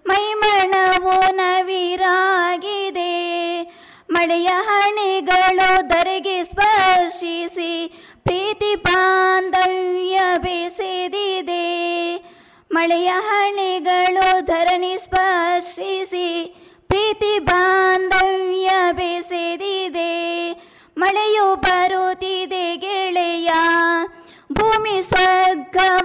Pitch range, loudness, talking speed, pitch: 350-380 Hz, -18 LUFS, 50 wpm, 370 Hz